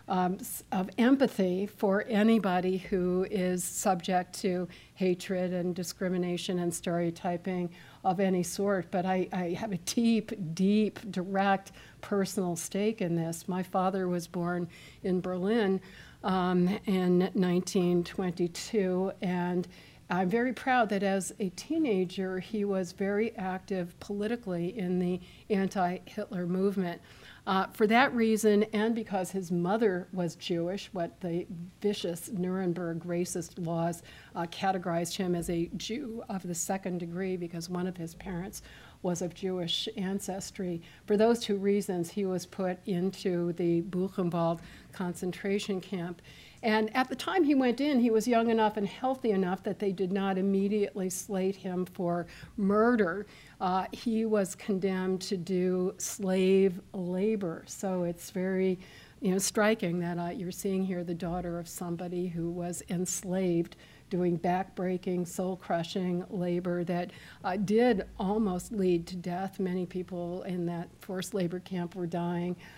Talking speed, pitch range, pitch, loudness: 145 wpm, 180-200 Hz, 185 Hz, -31 LUFS